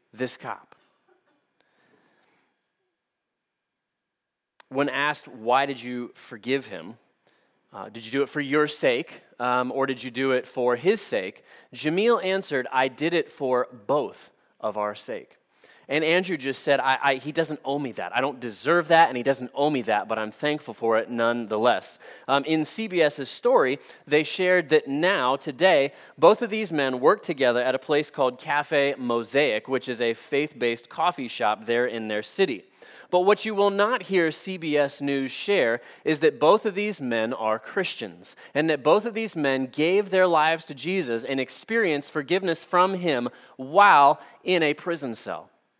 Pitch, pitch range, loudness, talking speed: 140 Hz, 125-165 Hz, -24 LUFS, 175 wpm